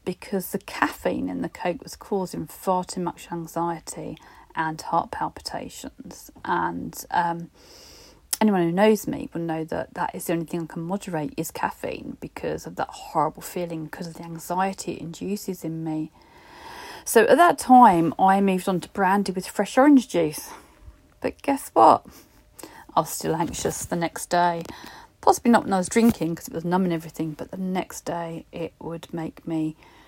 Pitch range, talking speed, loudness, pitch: 165-200 Hz, 180 wpm, -24 LUFS, 180 Hz